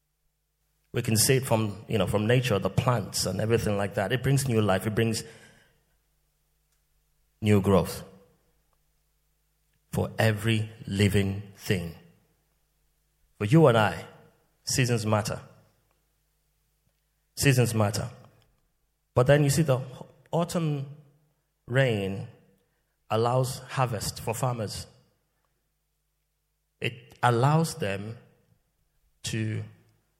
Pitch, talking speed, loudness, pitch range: 120 Hz, 100 wpm, -26 LUFS, 105-145 Hz